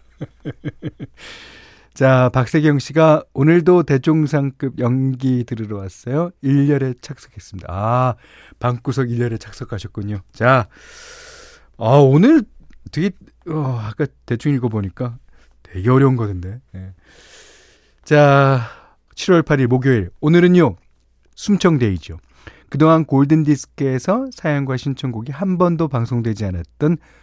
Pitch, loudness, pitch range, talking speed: 130 Hz, -17 LUFS, 110-155 Hz, 240 characters per minute